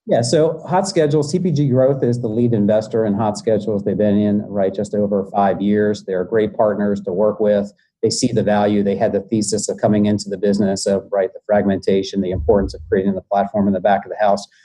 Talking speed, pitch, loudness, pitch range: 230 wpm, 105 Hz, -18 LUFS, 100-115 Hz